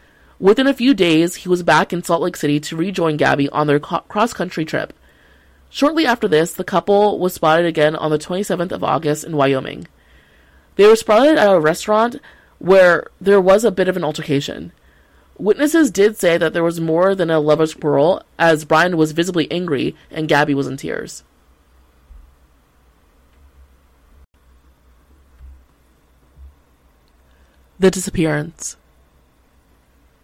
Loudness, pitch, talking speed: -16 LUFS, 150 Hz, 145 wpm